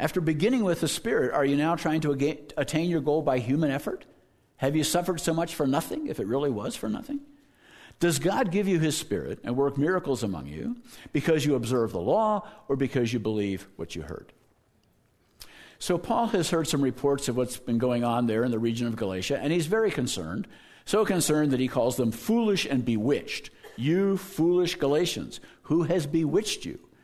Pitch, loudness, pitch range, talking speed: 155 Hz, -27 LUFS, 125-180 Hz, 200 wpm